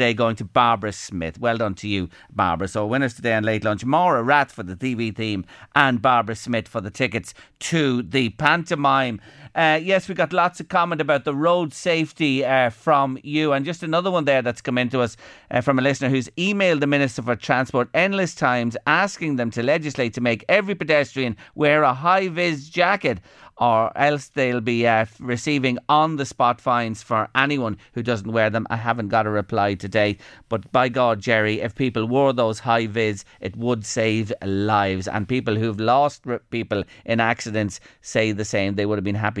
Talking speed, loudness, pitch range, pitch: 200 wpm, -21 LUFS, 110-145 Hz, 120 Hz